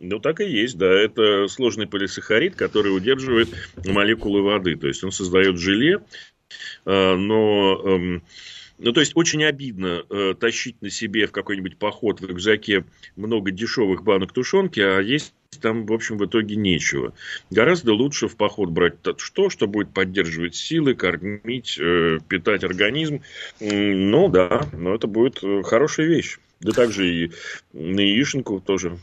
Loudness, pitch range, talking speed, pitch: -21 LUFS, 95-115 Hz, 145 wpm, 100 Hz